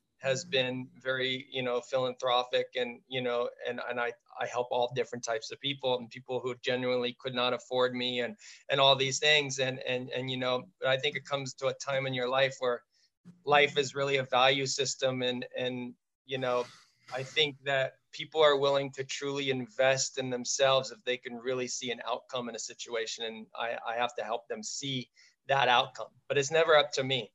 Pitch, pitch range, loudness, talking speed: 130 Hz, 125-135 Hz, -30 LUFS, 210 wpm